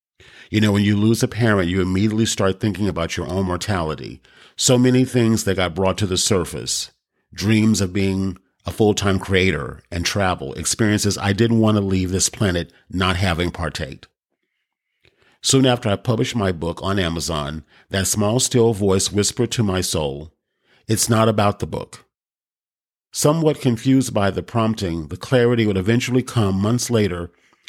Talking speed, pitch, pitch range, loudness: 165 wpm, 100 Hz, 90-115 Hz, -19 LUFS